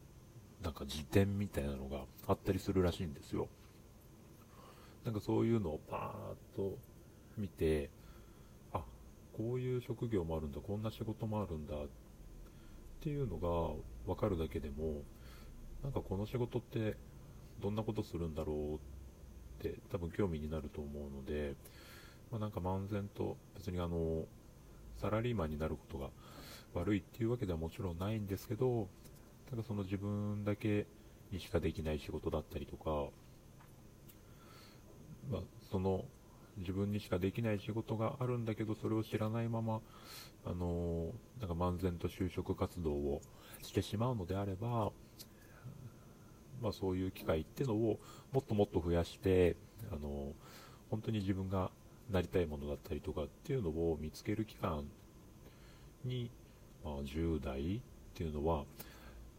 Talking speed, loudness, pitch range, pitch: 275 characters per minute, -40 LUFS, 80-110 Hz, 100 Hz